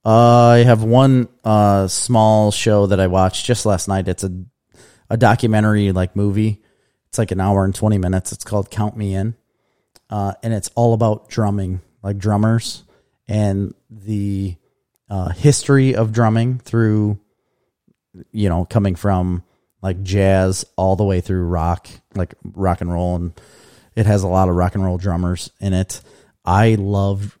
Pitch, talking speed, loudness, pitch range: 100 Hz, 165 wpm, -17 LUFS, 95-110 Hz